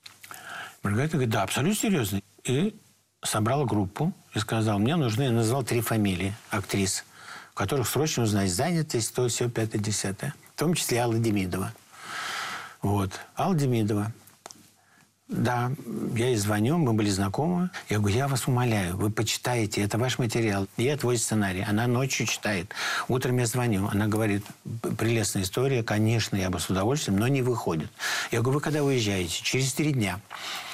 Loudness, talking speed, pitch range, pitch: -27 LUFS, 155 wpm, 105-130 Hz, 115 Hz